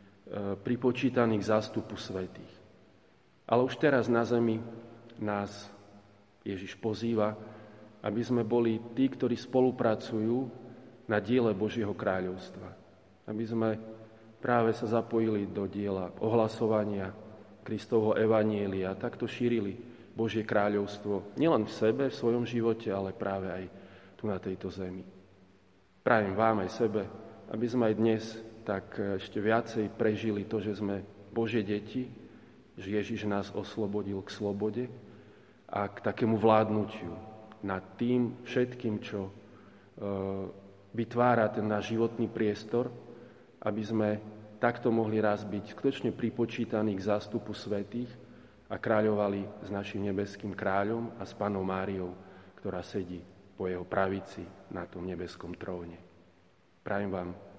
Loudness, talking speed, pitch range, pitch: -32 LUFS, 125 wpm, 100-115 Hz, 105 Hz